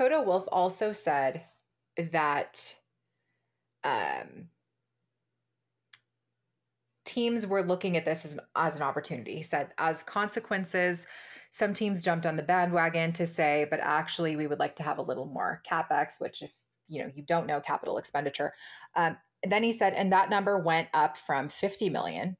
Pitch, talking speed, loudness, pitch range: 165 Hz, 165 wpm, -30 LUFS, 150-195 Hz